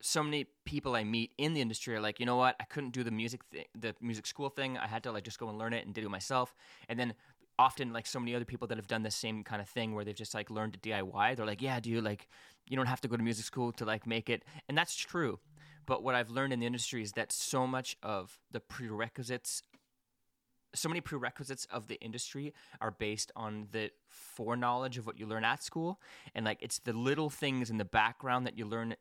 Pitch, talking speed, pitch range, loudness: 120 Hz, 255 wpm, 110-130 Hz, -36 LUFS